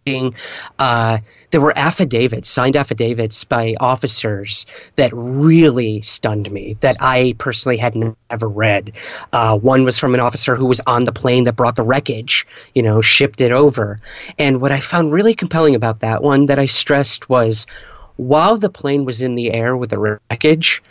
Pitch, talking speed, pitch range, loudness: 125 Hz, 175 wpm, 115-140 Hz, -15 LUFS